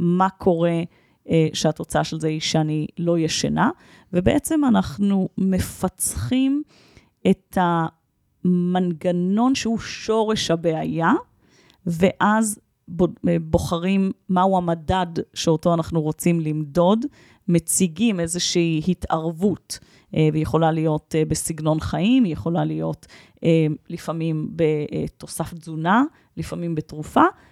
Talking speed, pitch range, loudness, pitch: 90 wpm, 160-190 Hz, -22 LUFS, 170 Hz